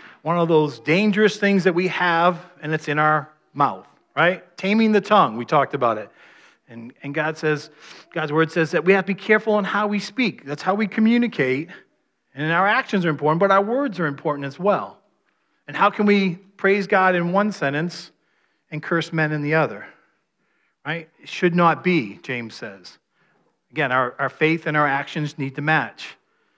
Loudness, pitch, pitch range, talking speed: -20 LUFS, 165 Hz, 150-195 Hz, 195 wpm